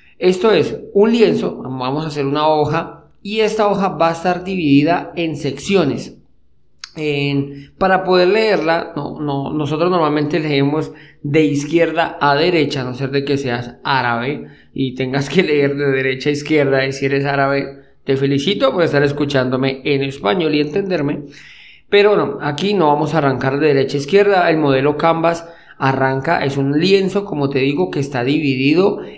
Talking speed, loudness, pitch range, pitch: 170 wpm, -16 LUFS, 140-170 Hz, 145 Hz